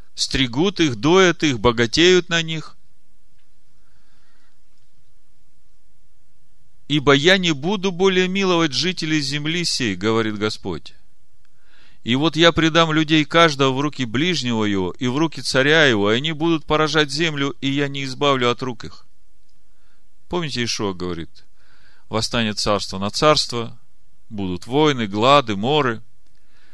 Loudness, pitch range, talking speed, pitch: -18 LUFS, 115-165 Hz, 125 wpm, 140 Hz